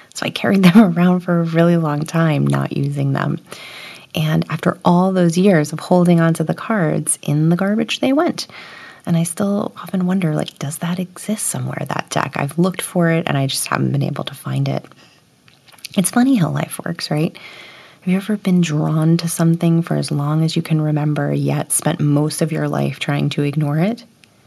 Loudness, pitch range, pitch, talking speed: -17 LUFS, 150-180 Hz, 165 Hz, 205 wpm